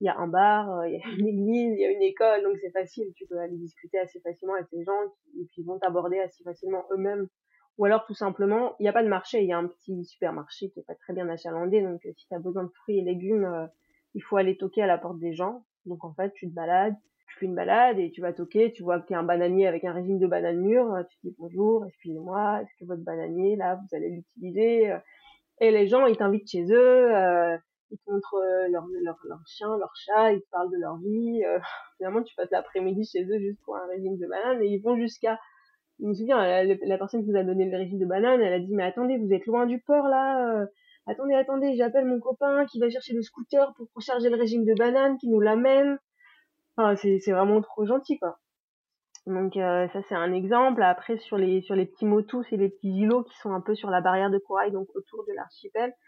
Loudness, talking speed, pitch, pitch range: -26 LUFS, 255 wpm, 200 Hz, 185-235 Hz